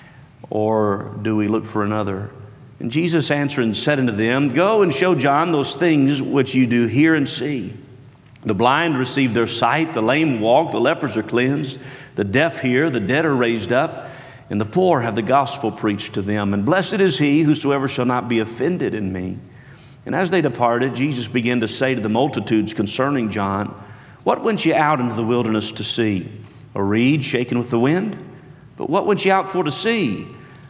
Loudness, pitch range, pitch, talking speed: -19 LUFS, 110-145 Hz, 130 Hz, 195 wpm